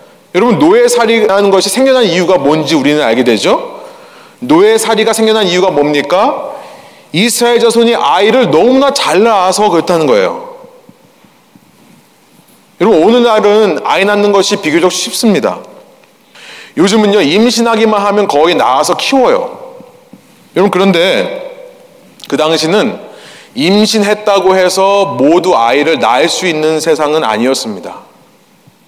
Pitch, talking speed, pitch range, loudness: 215 Hz, 290 characters per minute, 185-280 Hz, -9 LUFS